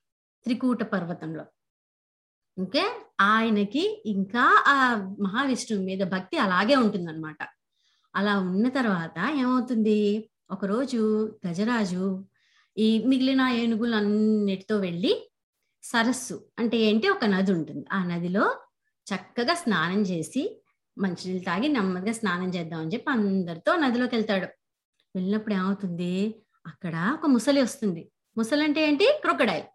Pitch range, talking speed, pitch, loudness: 190-250 Hz, 110 wpm, 215 Hz, -25 LUFS